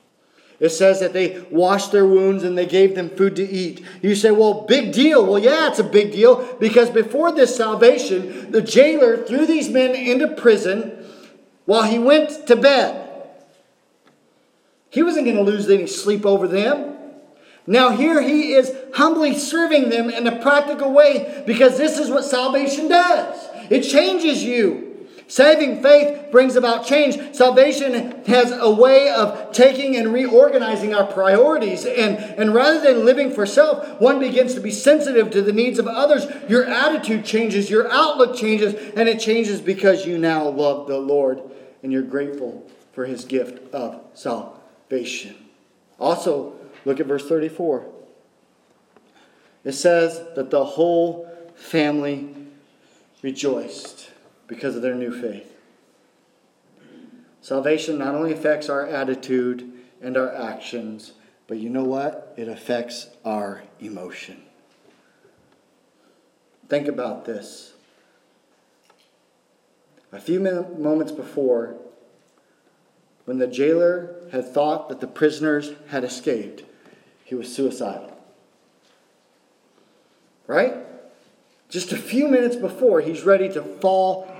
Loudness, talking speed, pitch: -18 LUFS, 135 wpm, 210 Hz